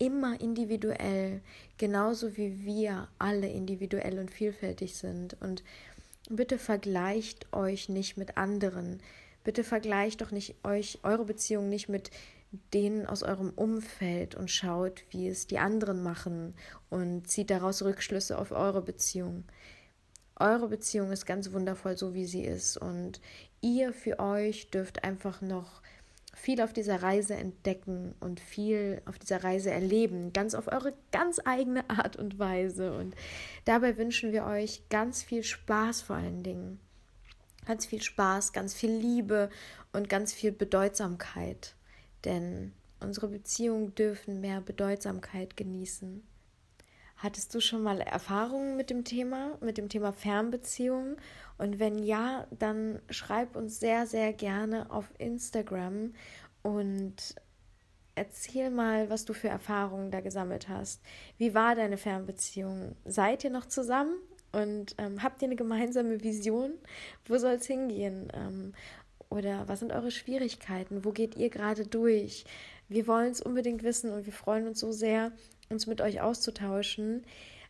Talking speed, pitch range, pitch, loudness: 145 wpm, 190-225 Hz, 205 Hz, -33 LUFS